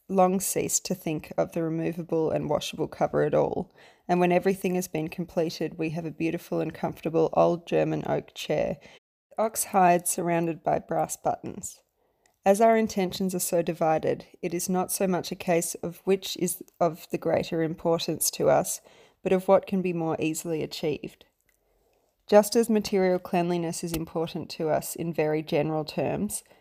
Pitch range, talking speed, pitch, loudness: 160-185 Hz, 170 wpm, 170 Hz, -27 LUFS